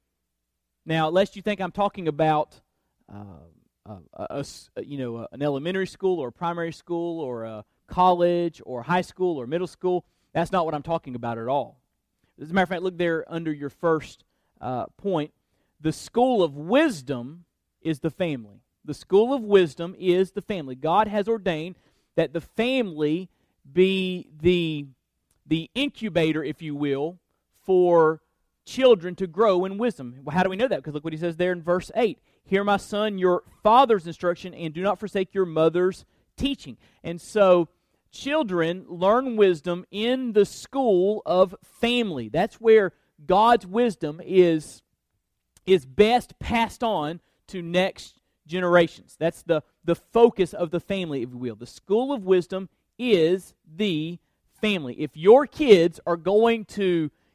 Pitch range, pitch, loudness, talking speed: 155-200 Hz, 175 Hz, -24 LUFS, 160 wpm